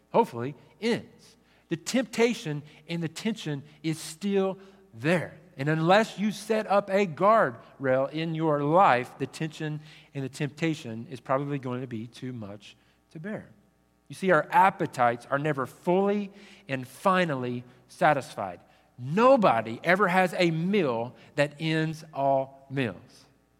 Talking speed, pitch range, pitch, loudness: 135 wpm, 130-185 Hz, 155 Hz, -27 LUFS